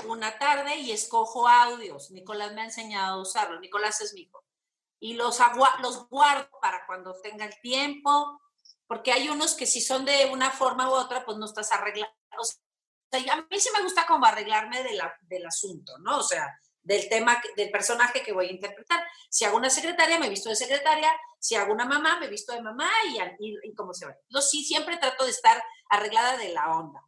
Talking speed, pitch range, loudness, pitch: 215 wpm, 215-295 Hz, -25 LUFS, 250 Hz